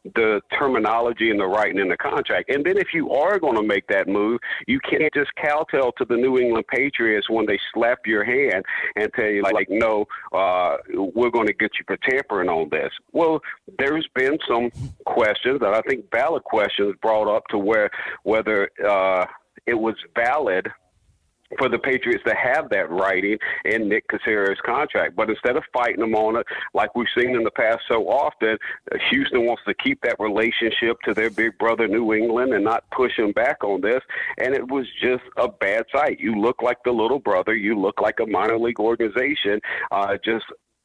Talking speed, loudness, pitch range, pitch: 195 wpm, -21 LUFS, 110-130 Hz, 115 Hz